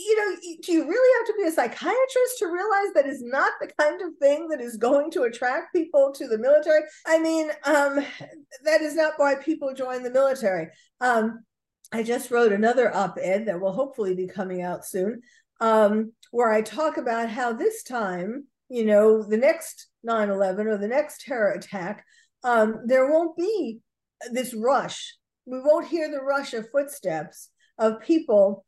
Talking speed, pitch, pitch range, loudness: 180 wpm, 270 Hz, 225-315 Hz, -24 LUFS